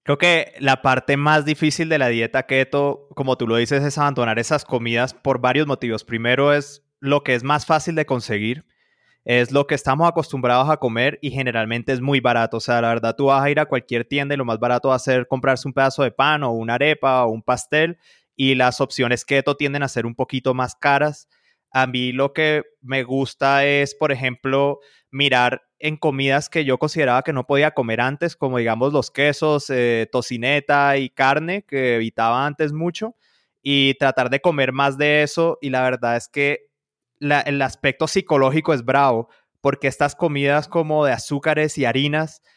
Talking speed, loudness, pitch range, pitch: 195 wpm, -19 LUFS, 125-145 Hz, 140 Hz